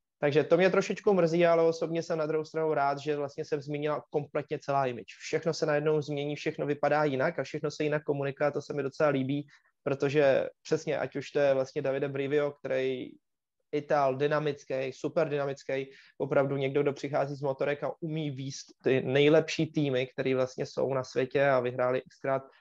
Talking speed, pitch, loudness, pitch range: 185 wpm, 145 Hz, -30 LUFS, 135-155 Hz